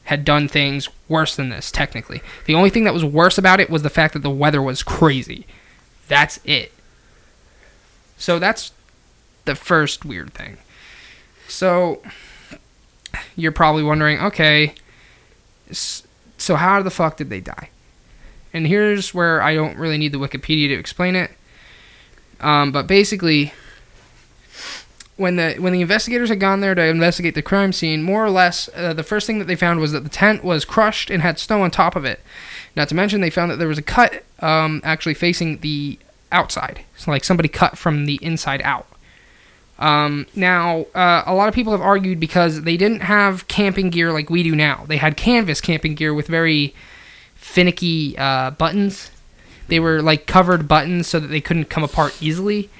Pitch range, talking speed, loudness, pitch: 150-185 Hz, 180 wpm, -17 LUFS, 165 Hz